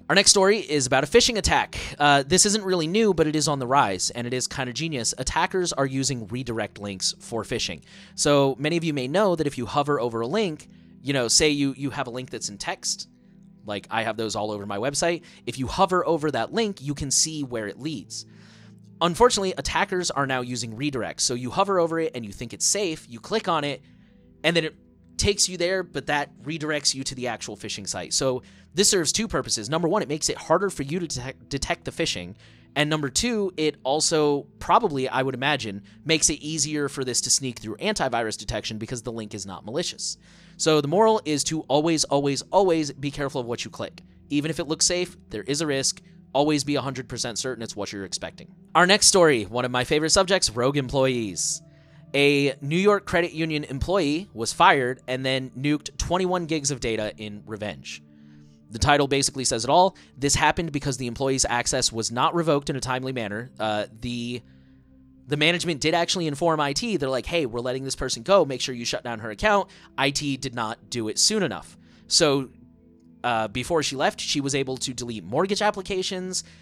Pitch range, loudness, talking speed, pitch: 120-165 Hz, -24 LUFS, 215 wpm, 140 Hz